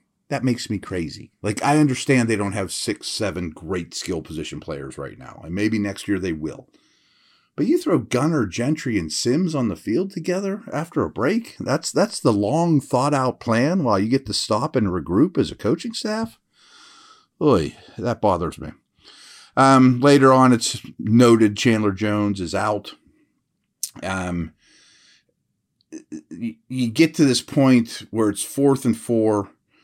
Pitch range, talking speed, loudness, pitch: 105-150 Hz, 160 wpm, -21 LUFS, 120 Hz